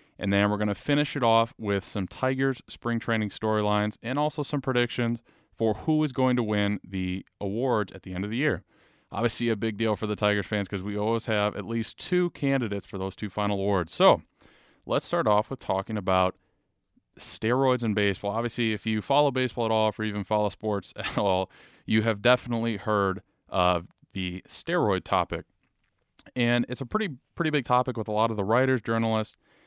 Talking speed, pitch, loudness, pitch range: 200 wpm, 110 Hz, -27 LUFS, 100-120 Hz